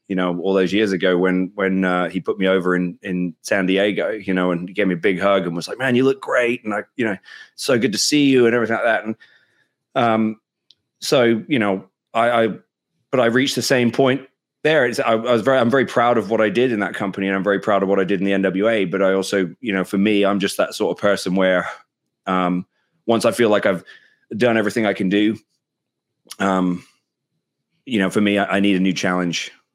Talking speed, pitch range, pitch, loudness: 245 wpm, 95-115 Hz, 100 Hz, -19 LUFS